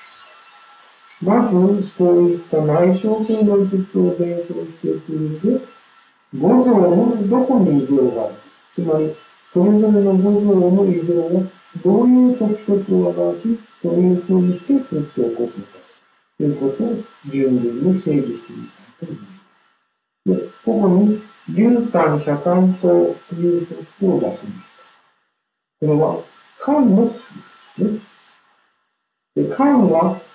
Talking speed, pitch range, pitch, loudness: 245 characters per minute, 155-215 Hz, 185 Hz, -17 LUFS